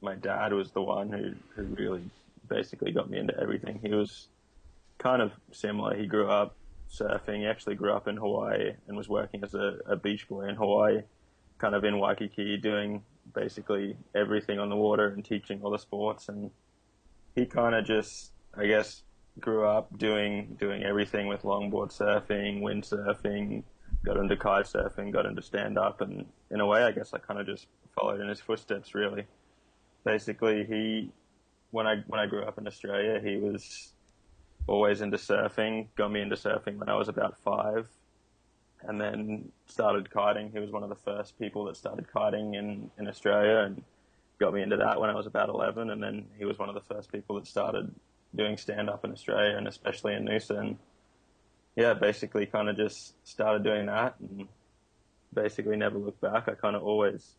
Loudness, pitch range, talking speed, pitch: -31 LUFS, 100-105 Hz, 185 wpm, 105 Hz